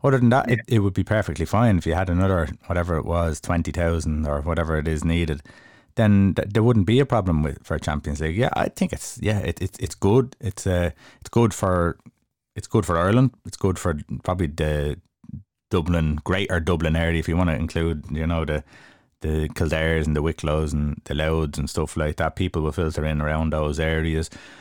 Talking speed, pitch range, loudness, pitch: 215 wpm, 80-100 Hz, -23 LUFS, 85 Hz